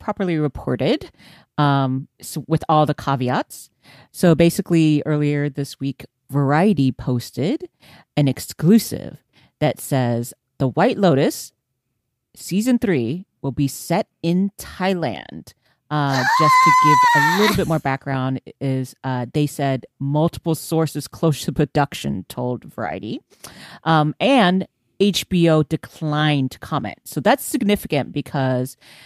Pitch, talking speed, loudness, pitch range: 150 Hz, 120 wpm, -19 LUFS, 130-175 Hz